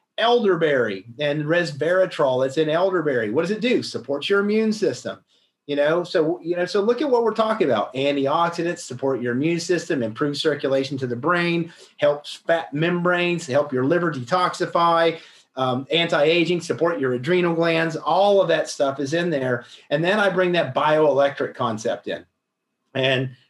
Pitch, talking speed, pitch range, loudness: 165 Hz, 165 wpm, 140-175 Hz, -21 LUFS